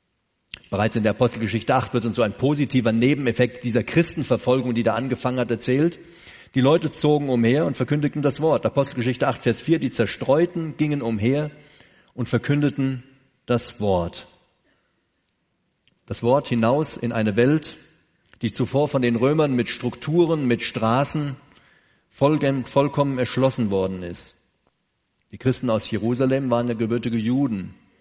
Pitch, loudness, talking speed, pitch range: 125 Hz, -22 LUFS, 140 wpm, 115-145 Hz